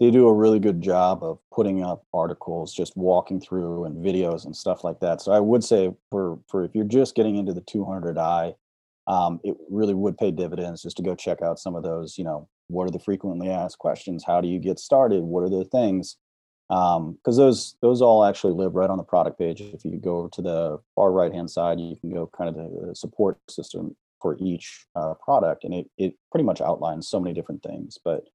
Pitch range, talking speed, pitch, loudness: 85-100 Hz, 235 wpm, 90 Hz, -24 LUFS